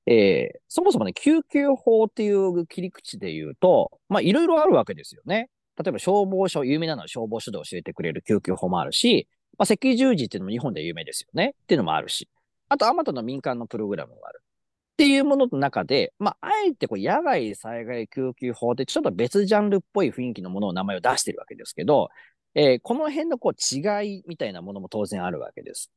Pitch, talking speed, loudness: 195 Hz, 440 characters per minute, -23 LUFS